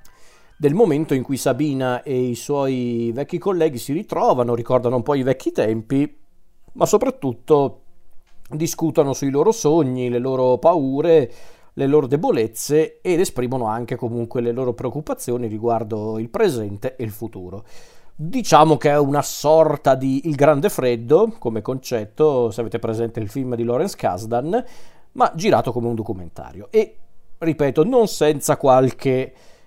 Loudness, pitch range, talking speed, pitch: -19 LUFS, 120-150 Hz, 145 wpm, 130 Hz